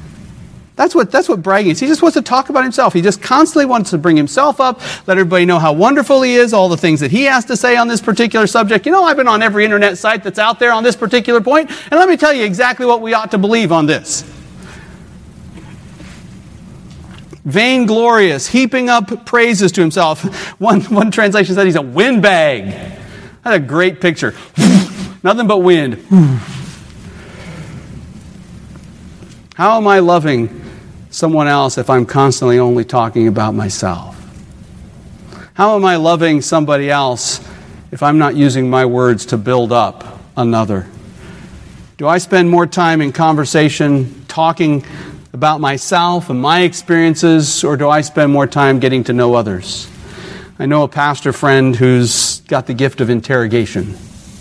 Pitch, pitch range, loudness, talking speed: 175 Hz, 135-220 Hz, -12 LUFS, 165 wpm